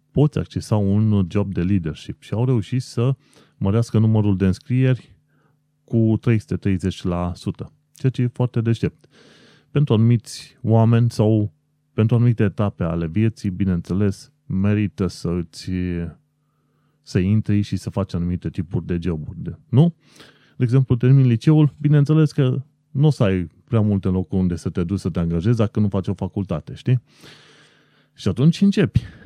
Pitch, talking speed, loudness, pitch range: 110 Hz, 150 wpm, -20 LUFS, 95-135 Hz